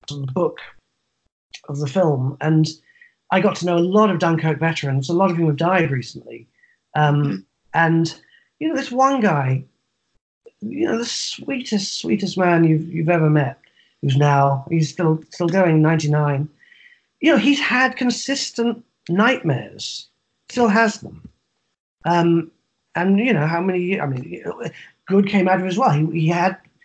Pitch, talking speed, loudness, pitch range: 175 Hz, 160 wpm, -19 LUFS, 155-230 Hz